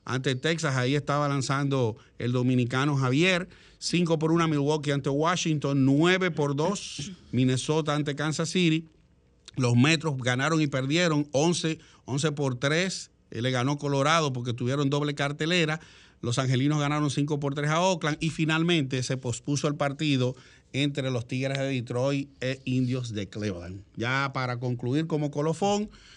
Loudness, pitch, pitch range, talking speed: -27 LUFS, 145 Hz, 130-155 Hz, 145 wpm